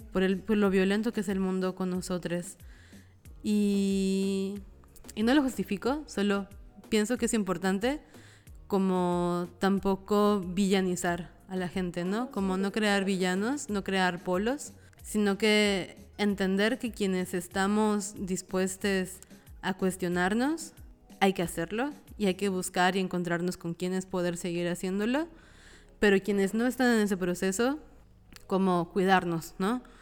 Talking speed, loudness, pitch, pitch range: 135 wpm, -29 LUFS, 195 Hz, 180-210 Hz